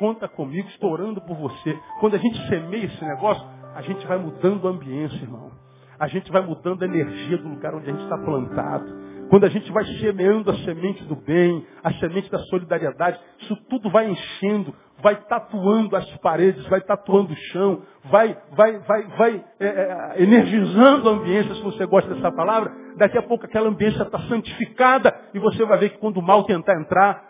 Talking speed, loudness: 190 wpm, -21 LUFS